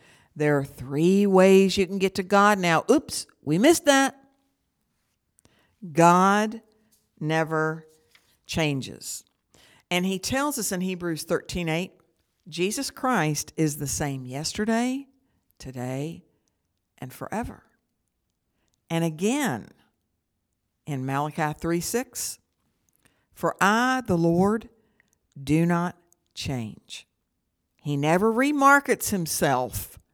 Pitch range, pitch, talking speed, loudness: 150-210 Hz, 175 Hz, 100 wpm, -24 LUFS